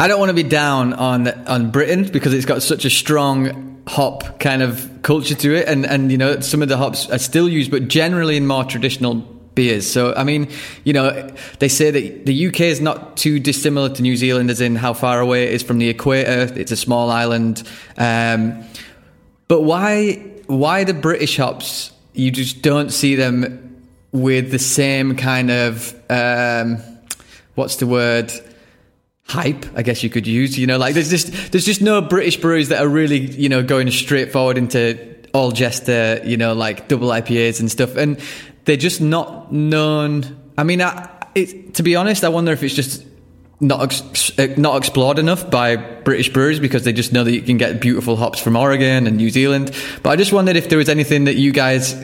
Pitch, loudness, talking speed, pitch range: 135 Hz, -16 LUFS, 205 wpm, 120-150 Hz